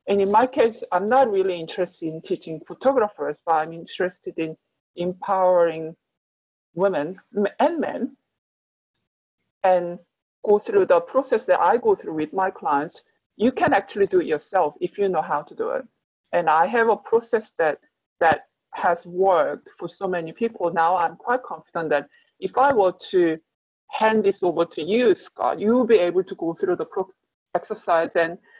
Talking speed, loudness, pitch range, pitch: 170 wpm, -22 LUFS, 170-260 Hz, 190 Hz